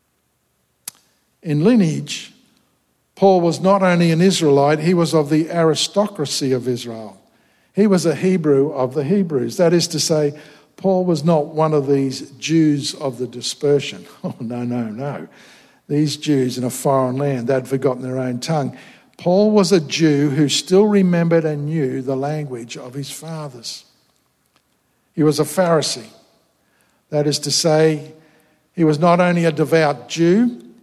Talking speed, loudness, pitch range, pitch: 155 wpm, -17 LUFS, 135-170 Hz, 150 Hz